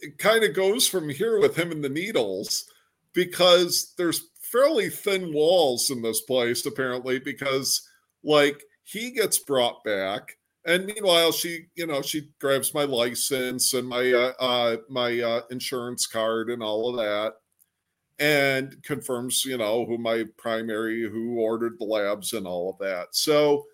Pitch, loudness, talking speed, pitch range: 135 Hz, -24 LUFS, 160 wpm, 115-165 Hz